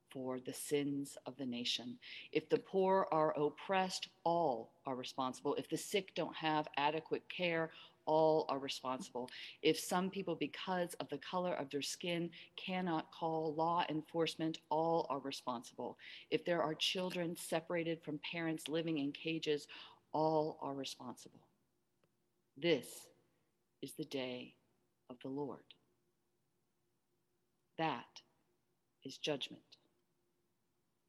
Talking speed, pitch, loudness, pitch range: 125 wpm, 155 Hz, -40 LUFS, 140-170 Hz